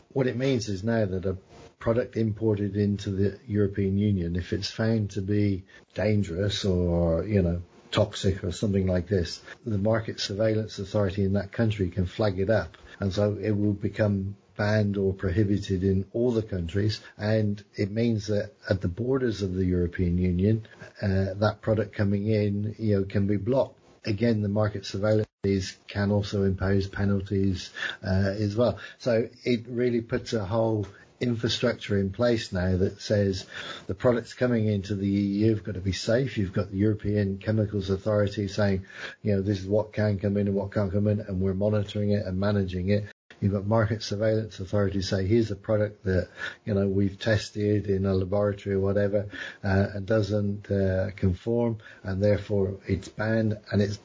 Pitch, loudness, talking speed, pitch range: 105 Hz, -27 LUFS, 180 wpm, 95-110 Hz